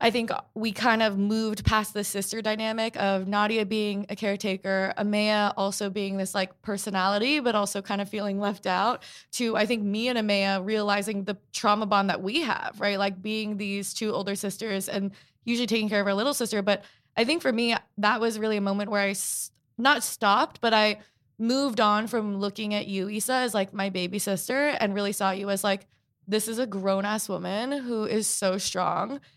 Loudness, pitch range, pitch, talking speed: -26 LUFS, 200-220 Hz, 205 Hz, 205 wpm